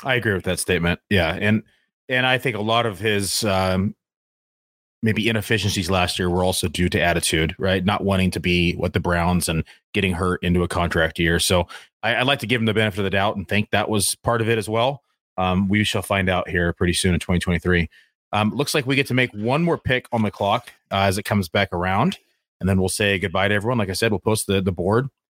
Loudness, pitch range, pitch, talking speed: -21 LUFS, 90-110 Hz, 100 Hz, 245 wpm